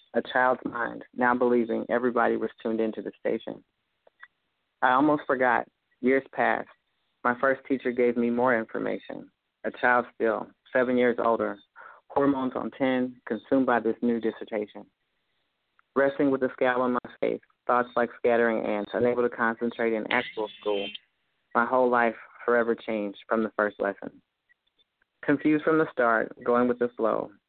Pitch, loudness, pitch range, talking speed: 120 Hz, -26 LUFS, 115-130 Hz, 155 wpm